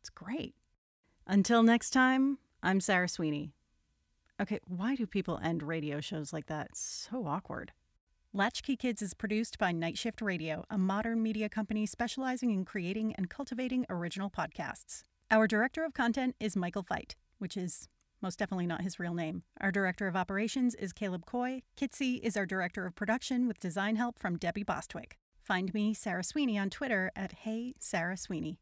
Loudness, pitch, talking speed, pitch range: -34 LUFS, 200 Hz, 175 wpm, 180-230 Hz